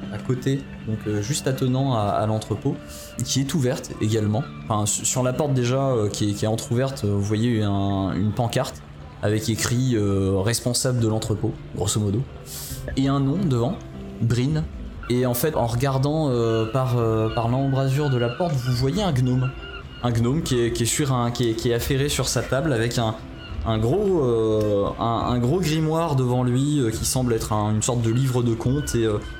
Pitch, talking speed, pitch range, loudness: 120 Hz, 200 wpm, 110-130 Hz, -23 LUFS